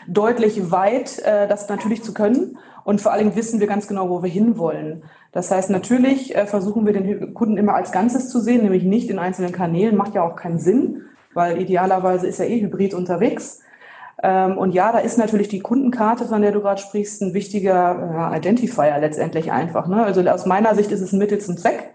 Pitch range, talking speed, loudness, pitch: 185-220 Hz, 195 wpm, -19 LUFS, 200 Hz